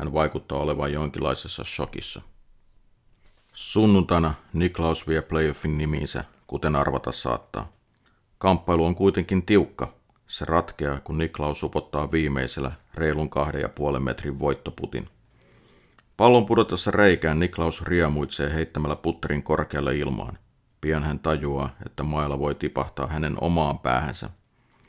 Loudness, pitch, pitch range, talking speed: -25 LUFS, 80 Hz, 70-85 Hz, 110 wpm